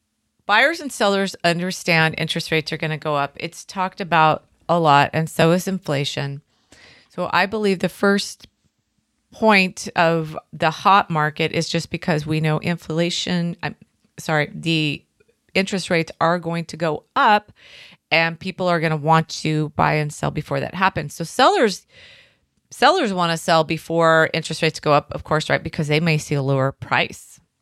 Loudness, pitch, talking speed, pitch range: -20 LUFS, 165 Hz, 175 wpm, 155-185 Hz